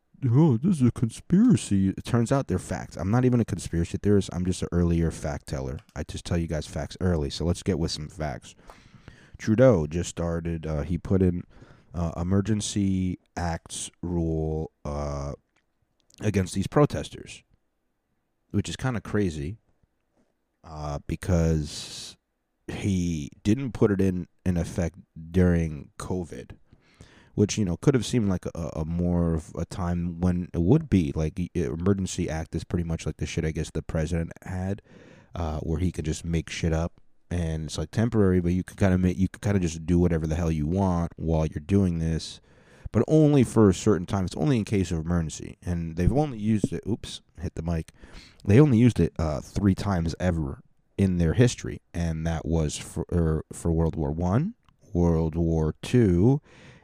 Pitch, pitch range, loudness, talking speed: 90 Hz, 80-100 Hz, -26 LUFS, 185 wpm